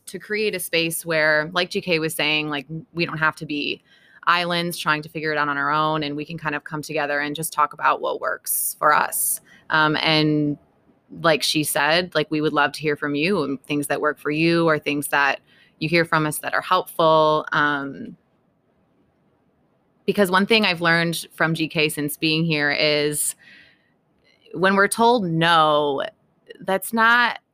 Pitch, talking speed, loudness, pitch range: 155 Hz, 185 wpm, -20 LUFS, 150-170 Hz